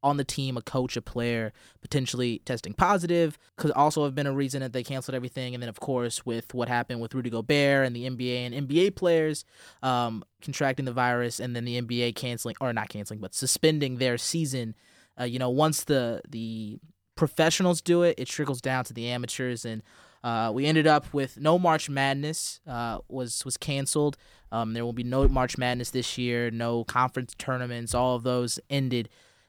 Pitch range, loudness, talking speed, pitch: 120-140 Hz, -28 LUFS, 195 wpm, 125 Hz